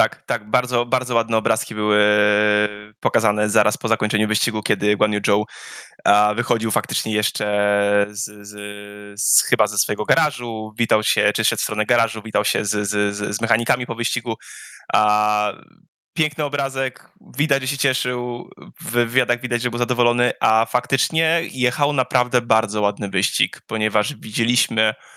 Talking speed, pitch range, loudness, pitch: 145 wpm, 105-125 Hz, -20 LUFS, 110 Hz